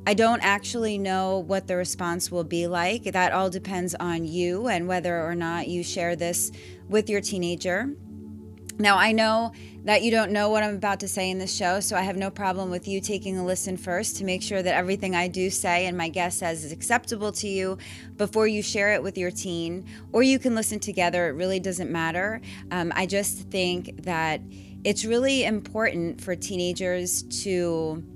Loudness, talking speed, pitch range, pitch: -25 LUFS, 200 wpm, 175-205 Hz, 185 Hz